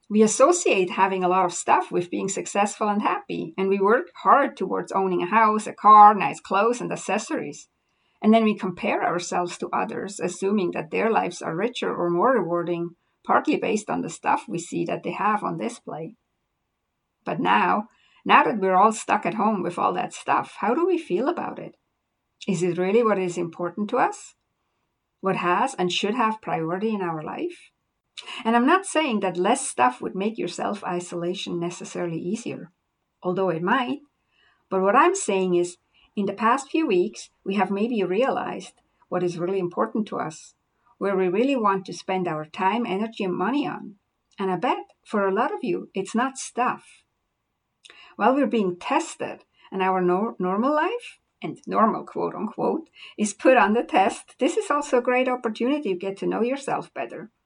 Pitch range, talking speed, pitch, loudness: 185-240 Hz, 190 wpm, 200 Hz, -23 LUFS